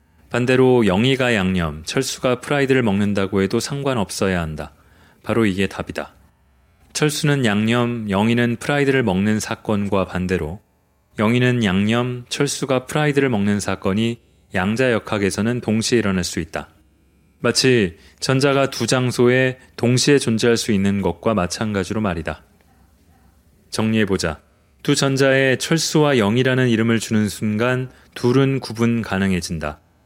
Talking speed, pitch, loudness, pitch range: 300 characters per minute, 110 Hz, -19 LUFS, 90-125 Hz